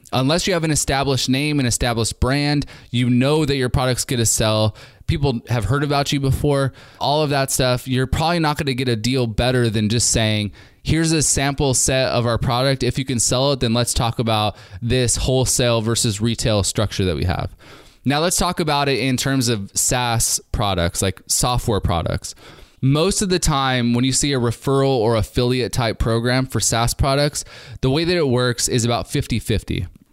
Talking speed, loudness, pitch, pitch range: 200 wpm, -19 LUFS, 125 Hz, 115-135 Hz